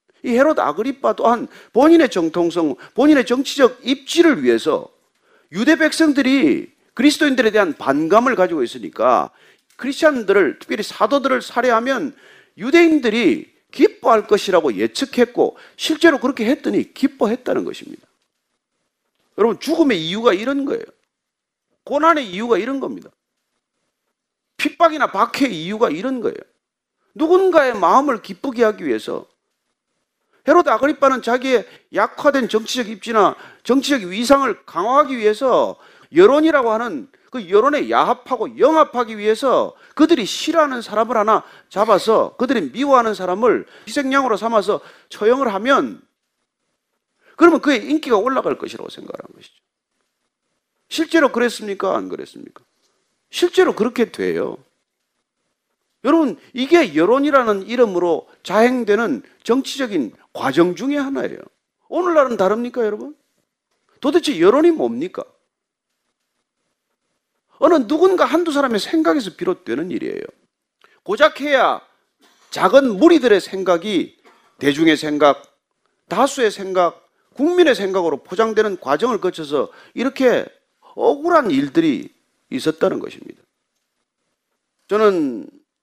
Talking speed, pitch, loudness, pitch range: 300 characters per minute, 270 Hz, -17 LUFS, 225-315 Hz